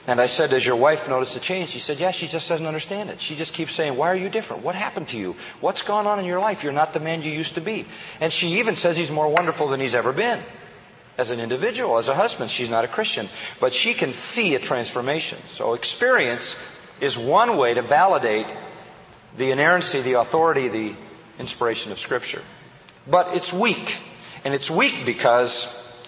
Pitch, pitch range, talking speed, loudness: 160 Hz, 130-180 Hz, 215 wpm, -22 LUFS